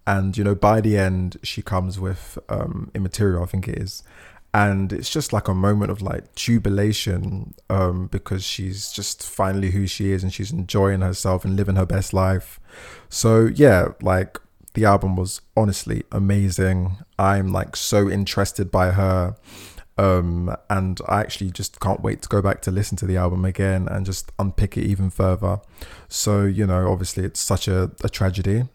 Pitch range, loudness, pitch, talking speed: 95-100 Hz, -21 LUFS, 95 Hz, 180 wpm